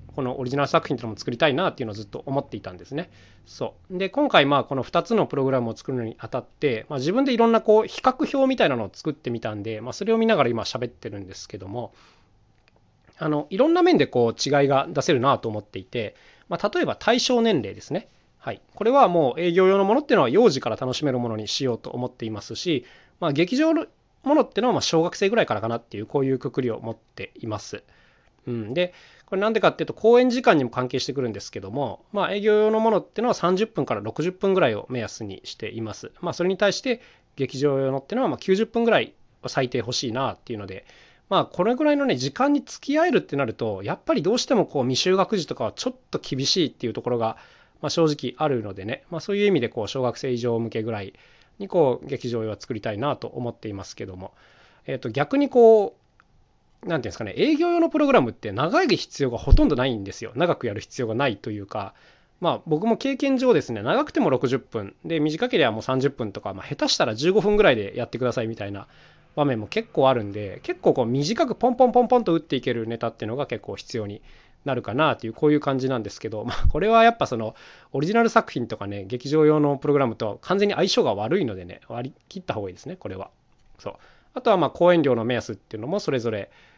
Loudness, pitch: -23 LUFS, 140 Hz